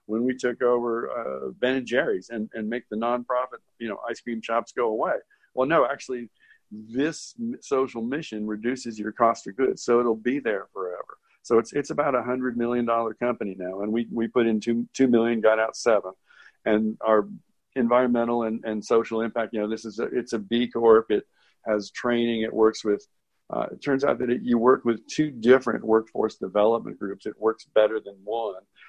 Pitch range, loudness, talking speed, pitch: 110-125 Hz, -25 LUFS, 205 wpm, 115 Hz